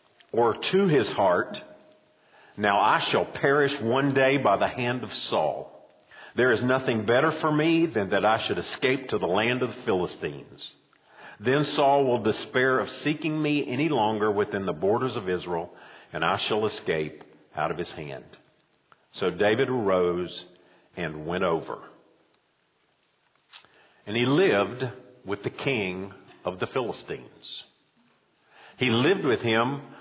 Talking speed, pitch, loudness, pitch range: 145 wpm, 125 Hz, -25 LUFS, 100-140 Hz